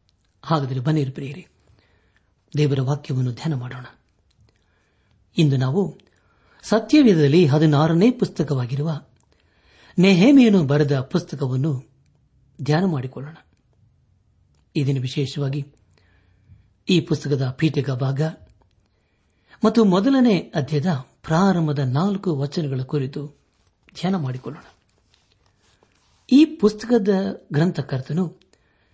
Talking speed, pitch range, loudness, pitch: 75 wpm, 110-165 Hz, -20 LUFS, 145 Hz